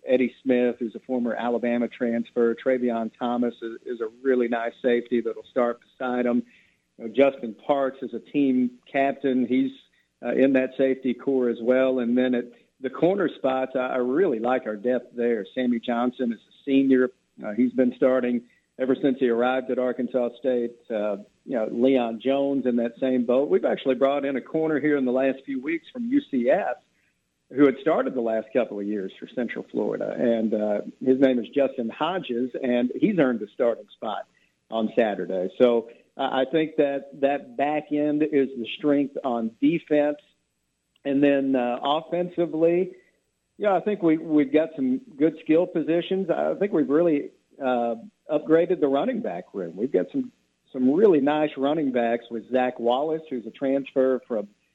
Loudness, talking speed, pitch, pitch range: -24 LUFS, 180 wpm, 130 Hz, 120-145 Hz